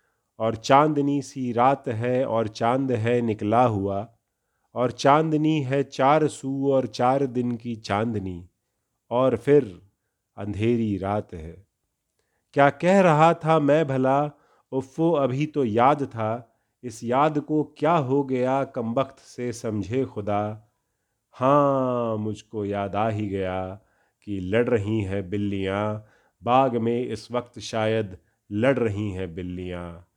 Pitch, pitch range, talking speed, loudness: 120 Hz, 105-135 Hz, 135 wpm, -24 LUFS